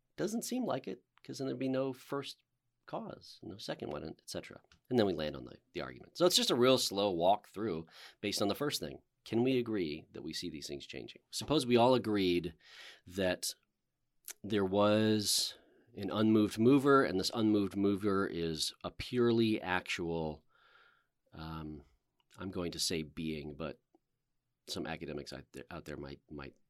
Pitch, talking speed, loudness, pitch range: 100 Hz, 175 wpm, -34 LUFS, 80-120 Hz